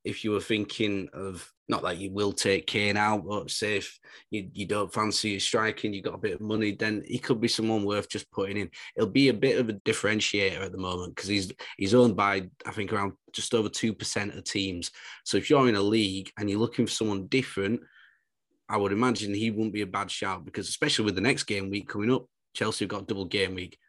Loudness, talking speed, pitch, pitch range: -28 LUFS, 245 wpm, 105 Hz, 100-110 Hz